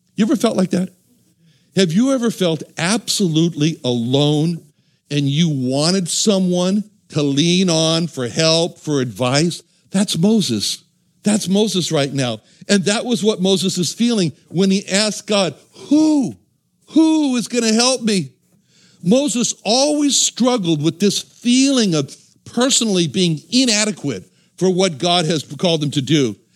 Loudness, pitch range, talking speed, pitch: -17 LUFS, 160-215 Hz, 145 wpm, 180 Hz